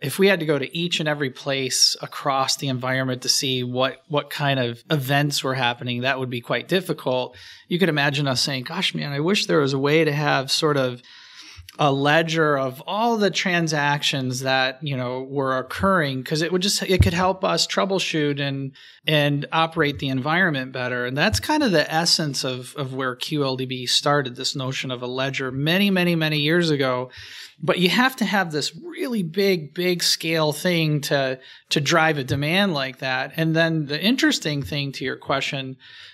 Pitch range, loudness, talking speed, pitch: 130-165 Hz, -21 LUFS, 195 wpm, 145 Hz